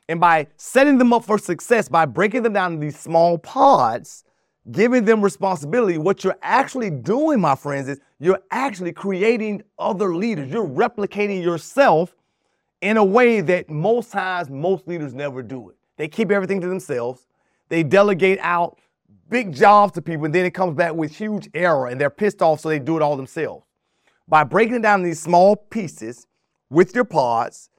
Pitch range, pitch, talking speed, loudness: 160-210 Hz, 180 Hz, 180 wpm, -19 LUFS